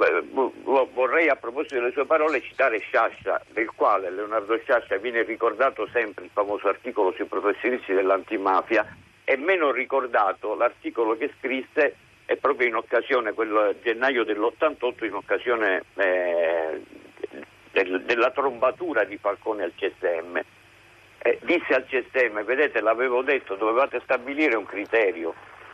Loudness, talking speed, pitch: -24 LUFS, 125 wpm, 315 Hz